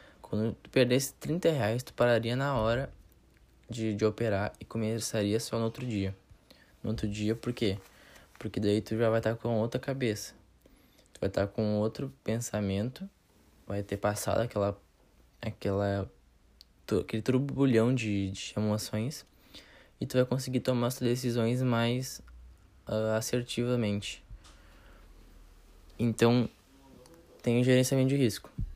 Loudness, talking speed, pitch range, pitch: -31 LUFS, 140 wpm, 100-120 Hz, 110 Hz